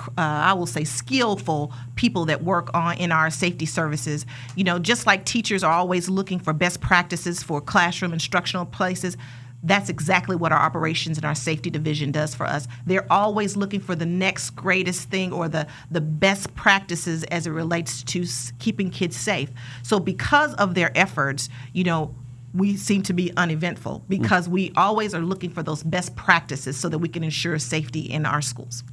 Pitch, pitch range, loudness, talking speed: 170 Hz, 150-185 Hz, -23 LUFS, 190 wpm